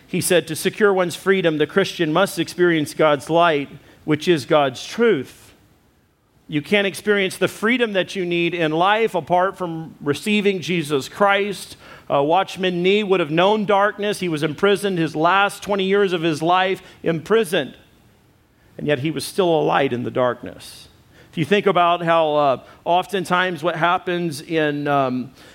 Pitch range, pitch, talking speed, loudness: 155-195 Hz, 175 Hz, 165 wpm, -19 LUFS